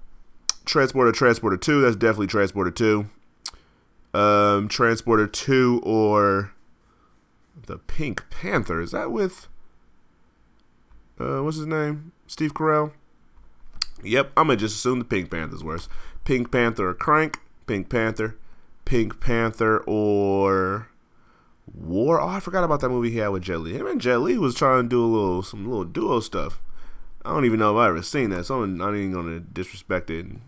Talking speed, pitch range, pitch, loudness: 160 wpm, 100-125 Hz, 110 Hz, -23 LUFS